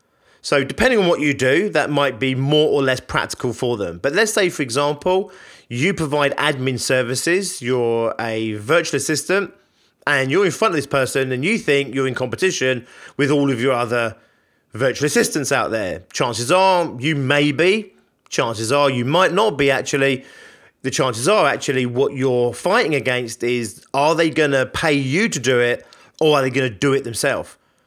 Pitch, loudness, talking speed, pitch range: 140 Hz, -18 LUFS, 185 wpm, 125-155 Hz